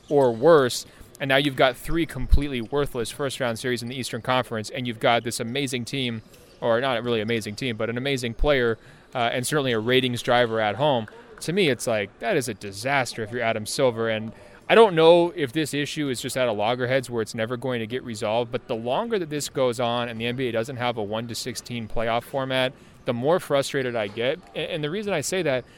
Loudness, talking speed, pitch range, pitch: -24 LUFS, 220 wpm, 115-140 Hz, 125 Hz